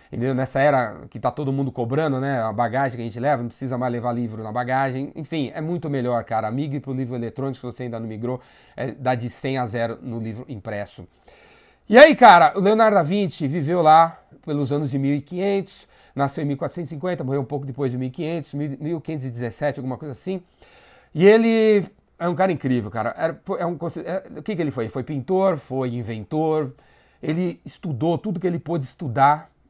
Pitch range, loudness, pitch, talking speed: 125-165 Hz, -21 LUFS, 140 Hz, 200 wpm